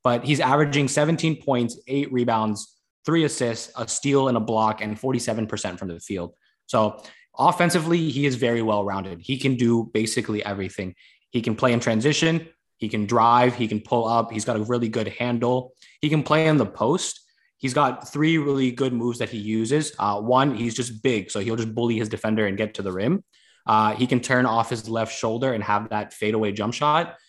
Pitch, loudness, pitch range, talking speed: 120 Hz, -23 LUFS, 110-135 Hz, 205 wpm